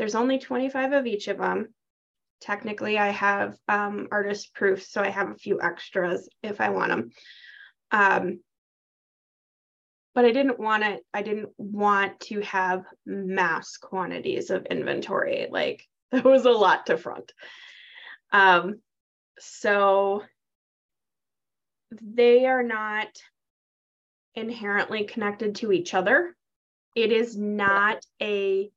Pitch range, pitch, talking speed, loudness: 200-245 Hz, 210 Hz, 125 wpm, -24 LUFS